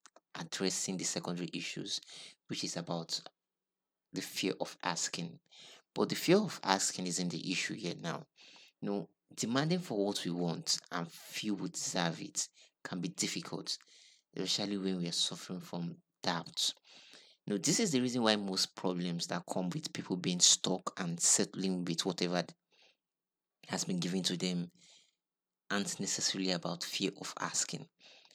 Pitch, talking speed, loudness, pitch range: 90 Hz, 155 wpm, -35 LUFS, 85-100 Hz